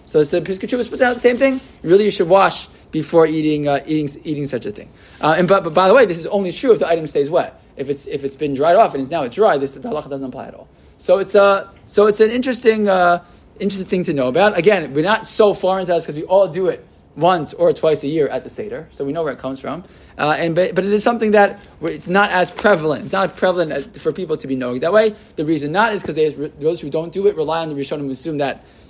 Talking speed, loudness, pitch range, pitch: 280 wpm, -17 LUFS, 150-205 Hz, 175 Hz